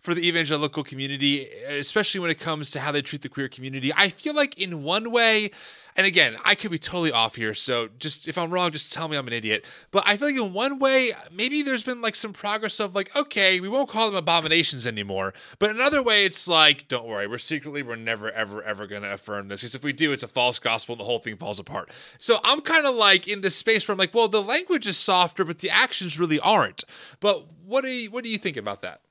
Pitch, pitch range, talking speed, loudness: 175 Hz, 135-215 Hz, 255 wpm, -22 LUFS